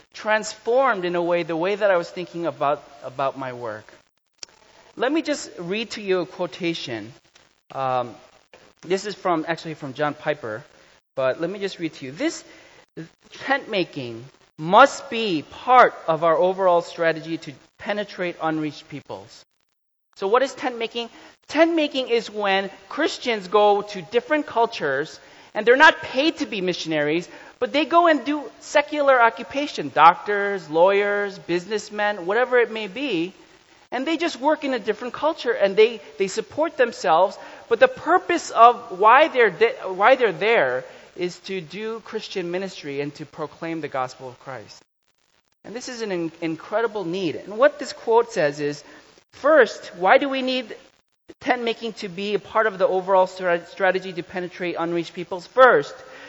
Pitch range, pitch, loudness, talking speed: 170-255 Hz, 200 Hz, -21 LUFS, 165 wpm